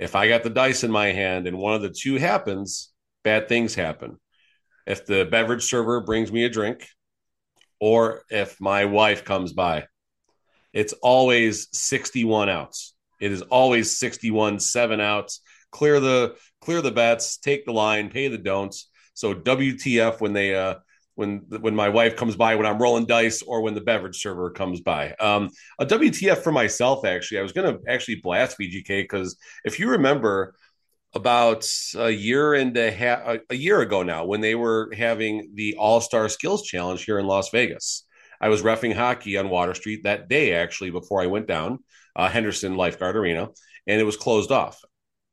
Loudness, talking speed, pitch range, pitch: -22 LUFS, 180 wpm, 100-120 Hz, 110 Hz